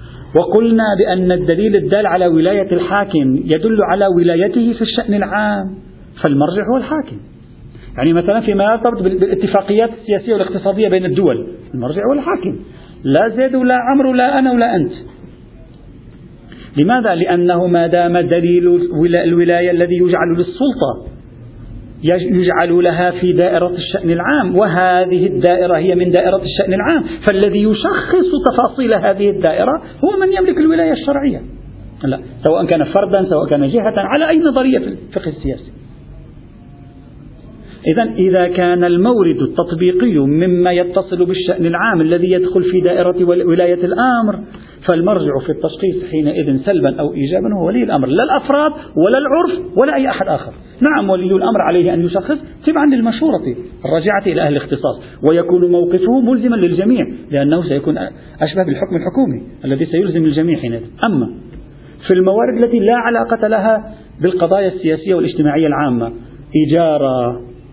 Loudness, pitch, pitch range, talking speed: -14 LUFS, 185 Hz, 170-225 Hz, 135 wpm